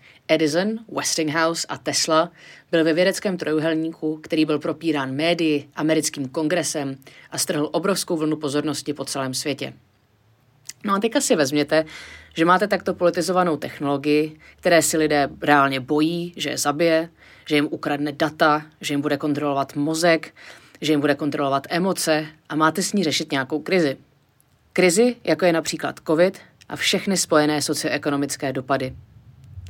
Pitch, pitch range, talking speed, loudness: 155 Hz, 145-170 Hz, 145 wpm, -21 LUFS